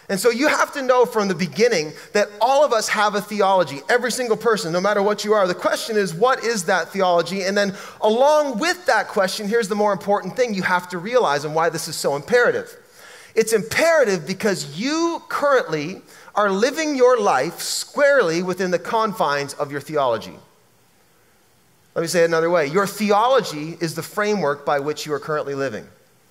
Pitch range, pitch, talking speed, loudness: 170-245 Hz, 205 Hz, 195 wpm, -20 LUFS